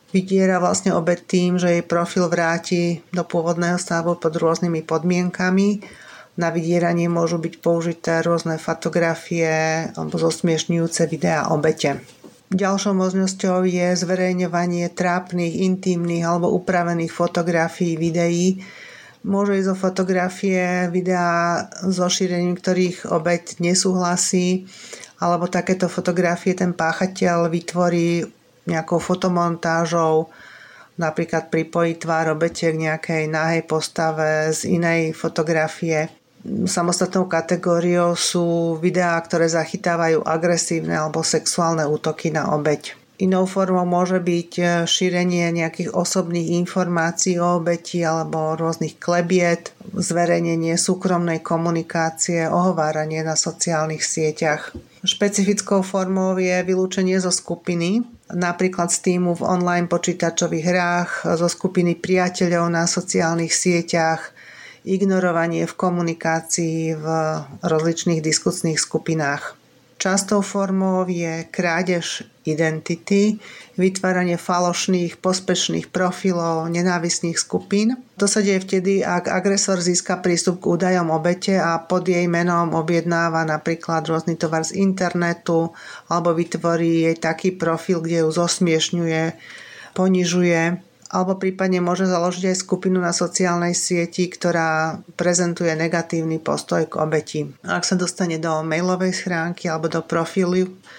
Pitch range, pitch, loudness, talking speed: 165-185 Hz, 175 Hz, -20 LUFS, 110 wpm